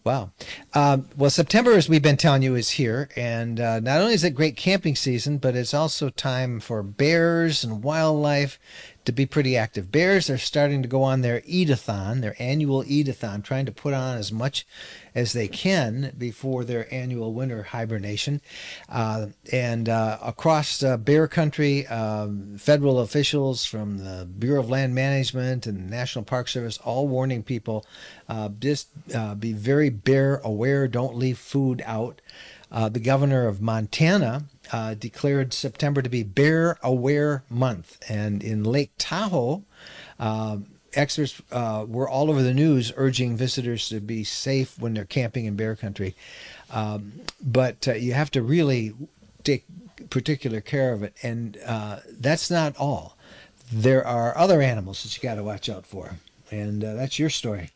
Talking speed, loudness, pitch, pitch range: 165 wpm, -24 LUFS, 130 Hz, 115-140 Hz